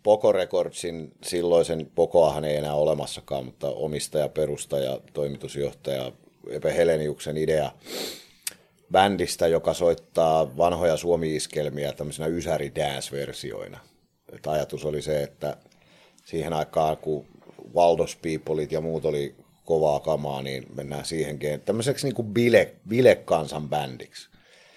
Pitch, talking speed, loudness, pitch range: 75 Hz, 105 wpm, -25 LUFS, 75-85 Hz